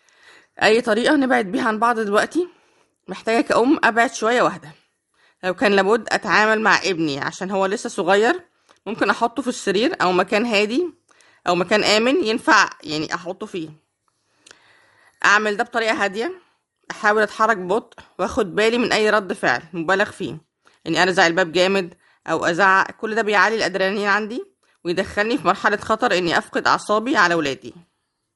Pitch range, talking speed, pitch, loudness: 185-230 Hz, 150 wpm, 210 Hz, -19 LUFS